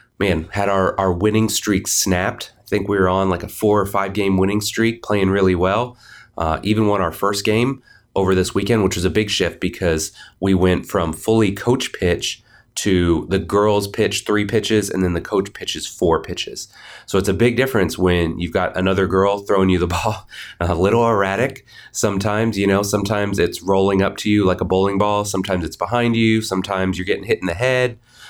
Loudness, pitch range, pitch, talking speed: -19 LUFS, 95-110 Hz, 100 Hz, 210 wpm